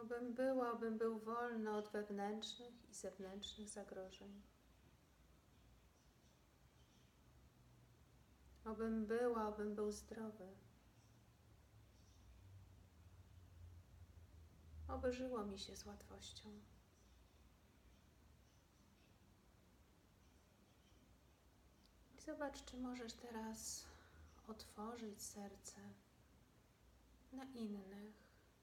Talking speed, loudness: 65 wpm, -48 LUFS